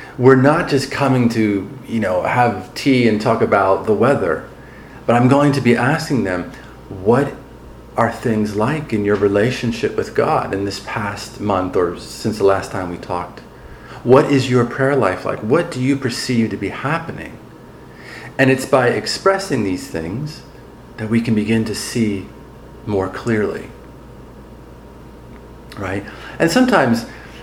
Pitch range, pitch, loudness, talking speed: 100-135 Hz, 115 Hz, -17 LUFS, 155 wpm